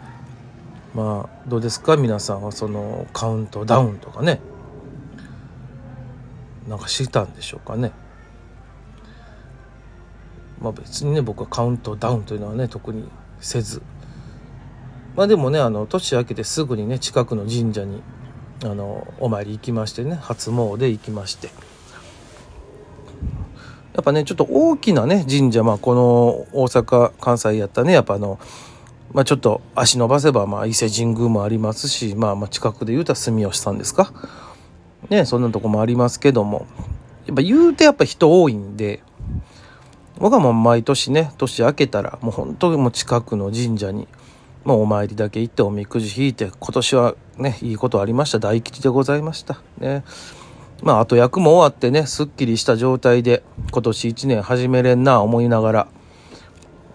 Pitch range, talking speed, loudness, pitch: 110-130 Hz, 315 characters per minute, -18 LUFS, 120 Hz